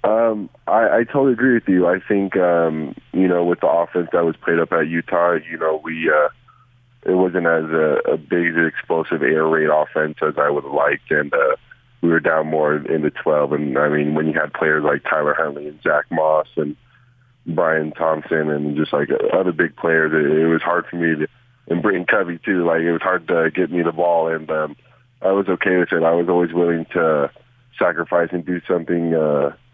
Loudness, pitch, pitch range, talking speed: -18 LUFS, 85 Hz, 80-90 Hz, 220 wpm